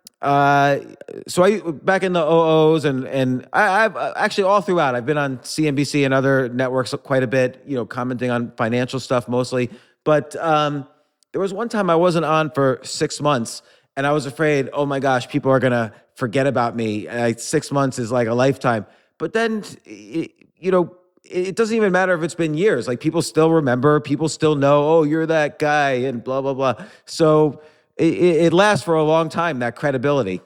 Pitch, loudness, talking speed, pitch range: 145 Hz, -19 LUFS, 205 wpm, 130-160 Hz